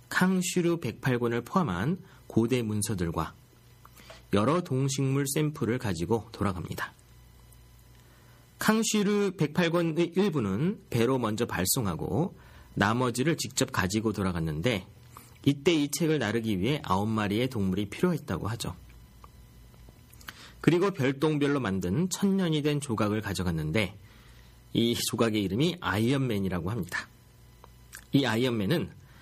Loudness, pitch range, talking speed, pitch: -28 LUFS, 100-150 Hz, 265 characters per minute, 115 Hz